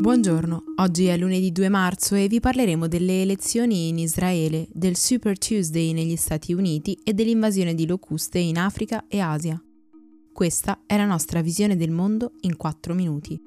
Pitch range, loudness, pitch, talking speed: 165-210 Hz, -23 LUFS, 185 Hz, 165 wpm